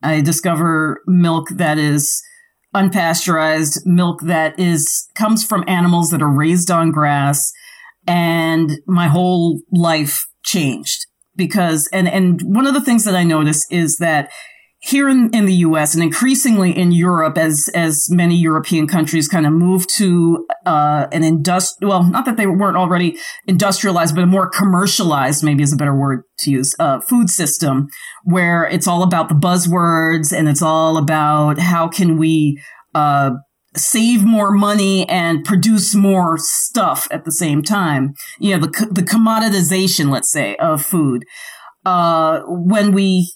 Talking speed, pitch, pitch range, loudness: 155 wpm, 170 Hz, 160-190 Hz, -14 LUFS